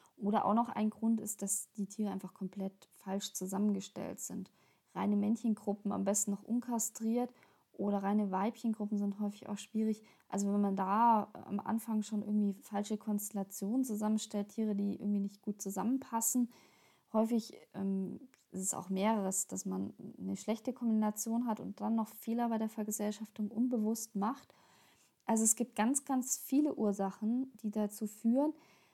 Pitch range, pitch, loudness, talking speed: 200-225 Hz, 210 Hz, -36 LUFS, 155 wpm